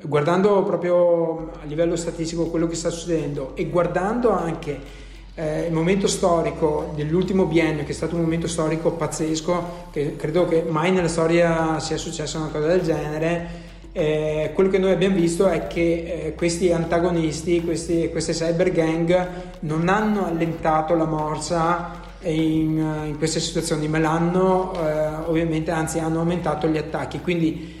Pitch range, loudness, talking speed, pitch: 160-175 Hz, -22 LUFS, 155 wpm, 165 Hz